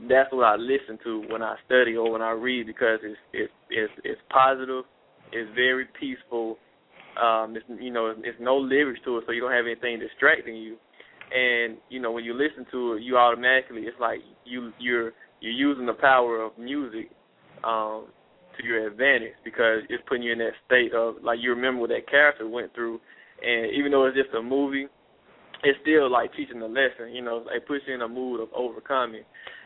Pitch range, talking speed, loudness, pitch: 115-135 Hz, 205 wpm, -25 LUFS, 120 Hz